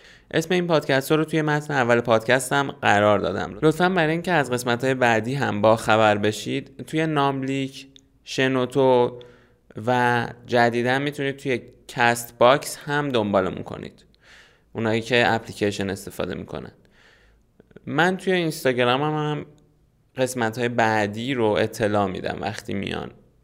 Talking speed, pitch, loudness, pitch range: 135 wpm, 125 Hz, -22 LUFS, 115-145 Hz